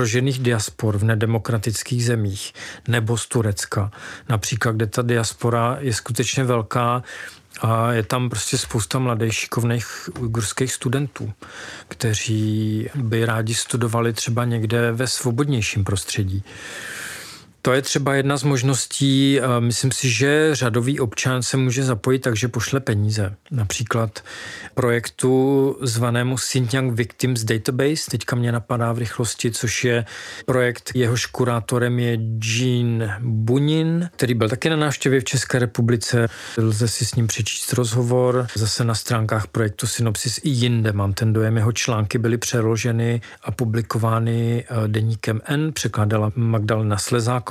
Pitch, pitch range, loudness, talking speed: 120 Hz, 115-130 Hz, -21 LUFS, 130 wpm